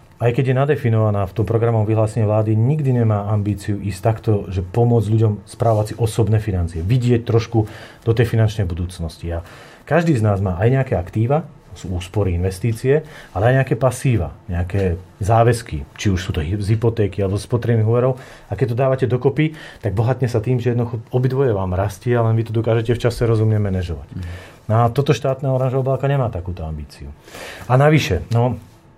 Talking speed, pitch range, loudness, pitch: 180 wpm, 100-125 Hz, -19 LUFS, 115 Hz